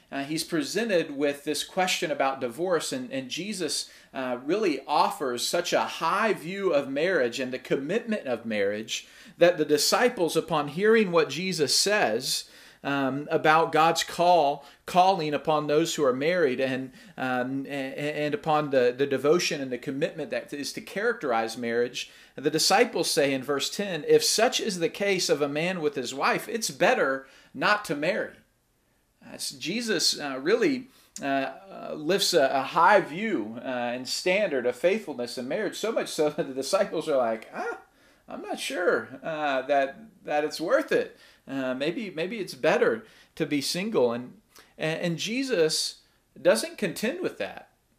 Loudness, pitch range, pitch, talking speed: -26 LUFS, 135-185 Hz, 155 Hz, 165 wpm